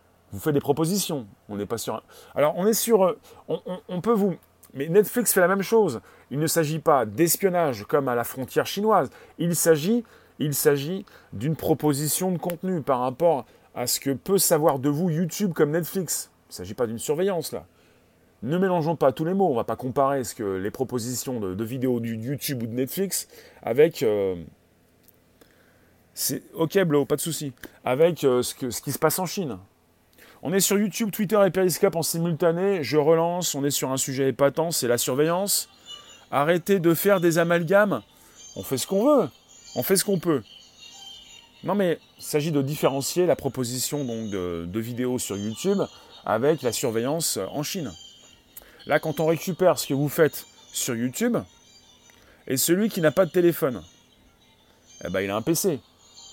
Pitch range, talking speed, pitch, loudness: 125-180 Hz, 190 wpm, 150 Hz, -24 LUFS